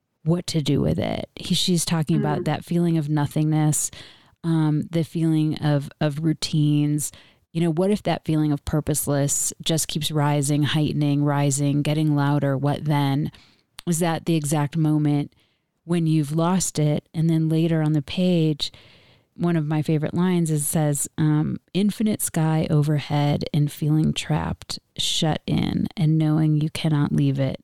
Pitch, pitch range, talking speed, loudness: 155 Hz, 145-165 Hz, 160 wpm, -22 LUFS